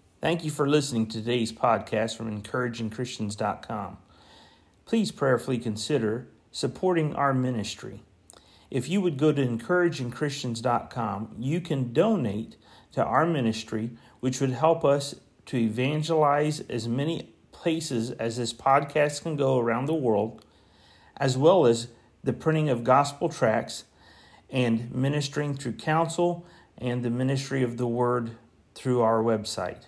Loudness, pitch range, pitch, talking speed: -27 LUFS, 115-145 Hz, 125 Hz, 130 wpm